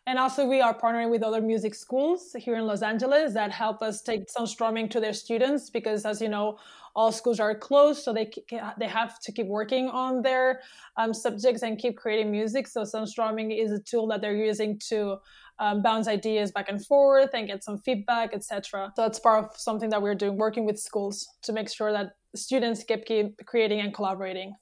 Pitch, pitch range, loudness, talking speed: 220 Hz, 210-235 Hz, -27 LUFS, 205 wpm